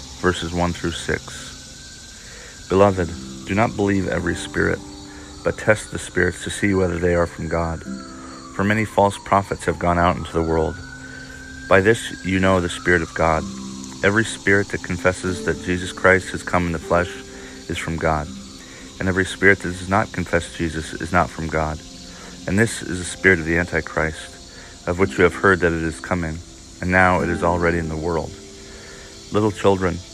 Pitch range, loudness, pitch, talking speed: 80-90 Hz, -20 LUFS, 85 Hz, 185 wpm